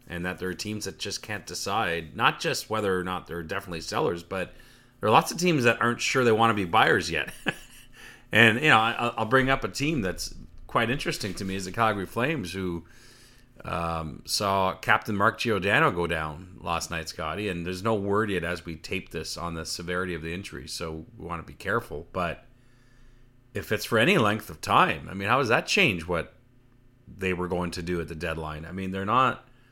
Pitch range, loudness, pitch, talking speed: 85-115 Hz, -26 LUFS, 95 Hz, 220 wpm